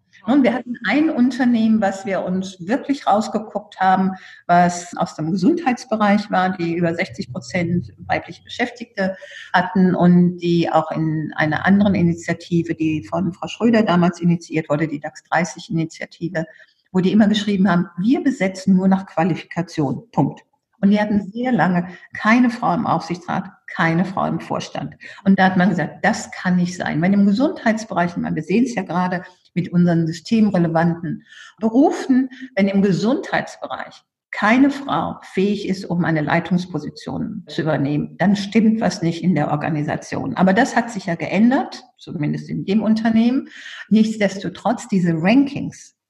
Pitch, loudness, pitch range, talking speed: 190 Hz, -19 LUFS, 170-220 Hz, 150 wpm